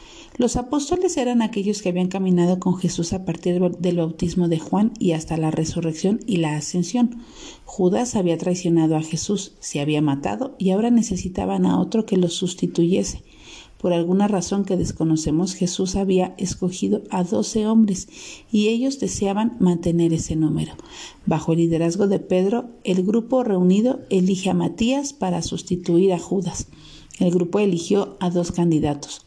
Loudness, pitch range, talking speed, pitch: -21 LUFS, 170-205 Hz, 155 wpm, 185 Hz